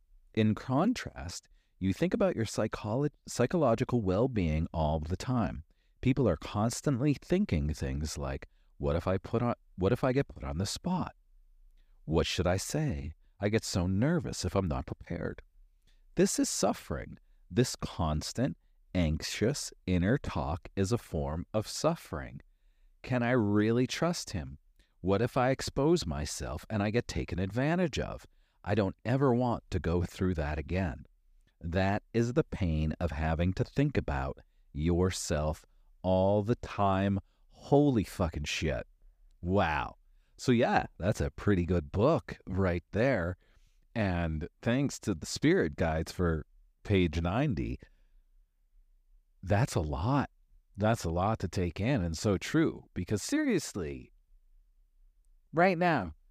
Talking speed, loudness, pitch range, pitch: 140 wpm, -31 LUFS, 80-115 Hz, 95 Hz